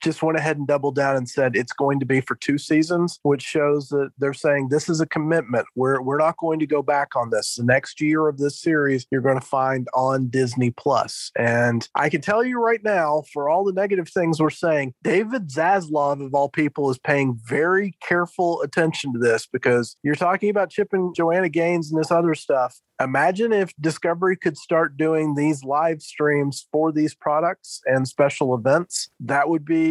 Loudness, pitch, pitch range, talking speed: -21 LUFS, 150 Hz, 135-165 Hz, 205 wpm